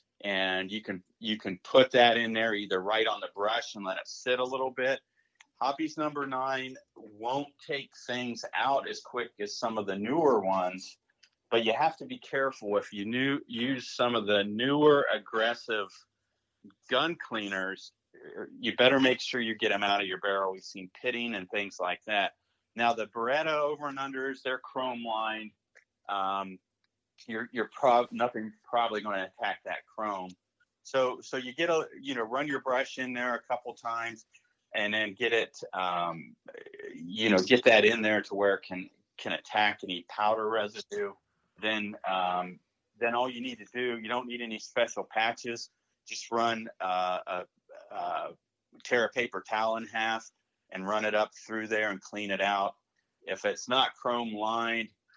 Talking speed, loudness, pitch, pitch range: 180 wpm, -30 LUFS, 115 Hz, 105-130 Hz